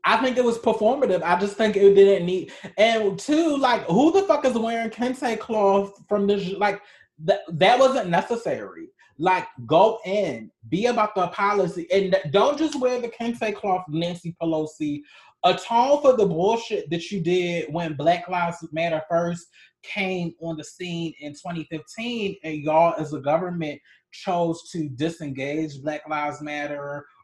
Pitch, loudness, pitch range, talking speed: 185 Hz, -23 LUFS, 165-225 Hz, 160 wpm